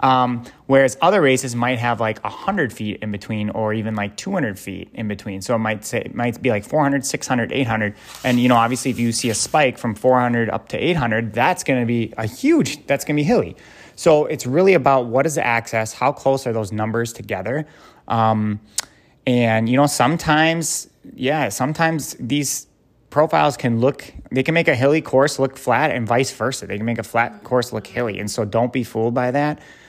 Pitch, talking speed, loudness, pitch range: 125 Hz, 210 wpm, -19 LUFS, 110-140 Hz